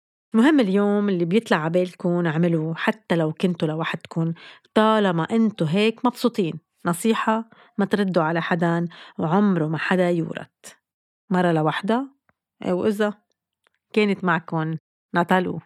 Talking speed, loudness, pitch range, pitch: 110 wpm, -22 LUFS, 170-220 Hz, 185 Hz